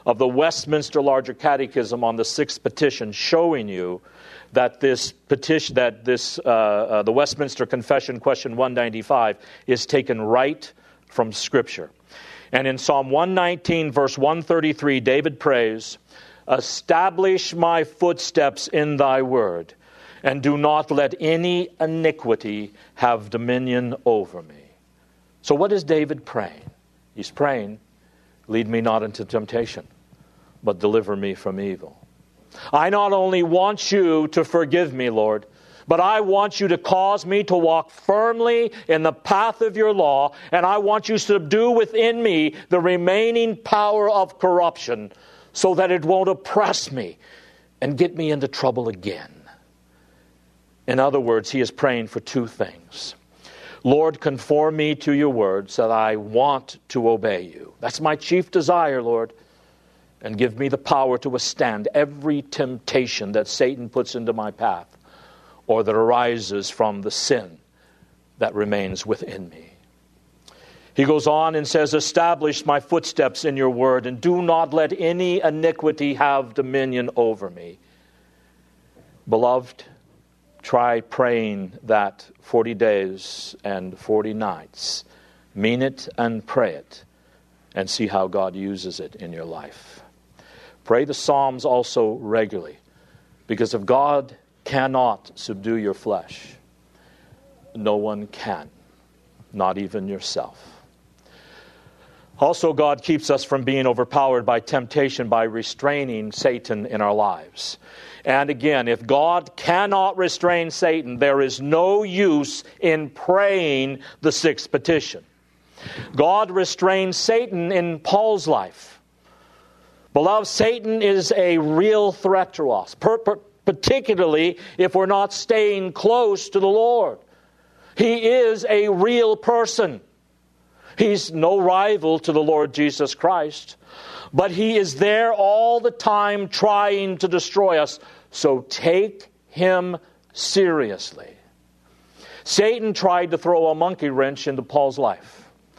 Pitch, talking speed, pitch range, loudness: 145 Hz, 135 wpm, 115-180 Hz, -20 LUFS